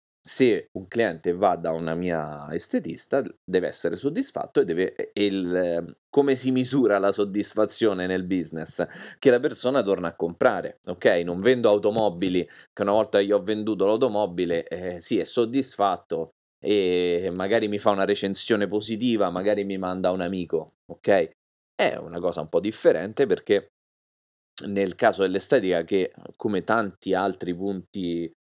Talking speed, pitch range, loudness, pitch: 150 wpm, 90-110 Hz, -25 LUFS, 100 Hz